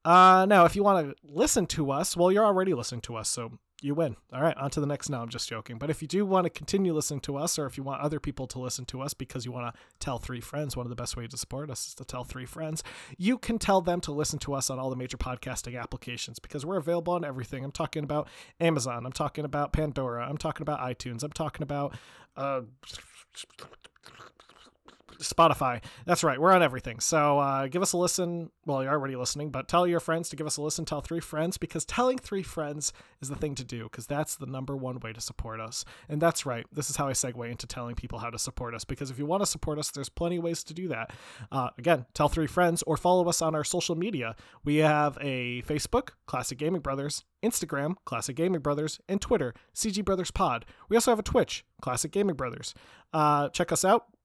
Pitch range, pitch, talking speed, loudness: 130-170 Hz, 150 Hz, 240 wpm, -29 LUFS